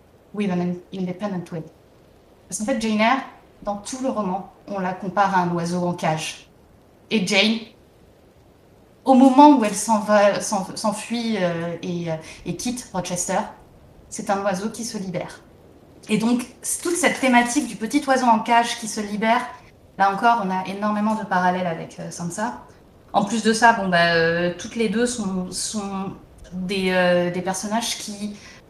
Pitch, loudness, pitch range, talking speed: 205 Hz, -21 LUFS, 185-230 Hz, 165 wpm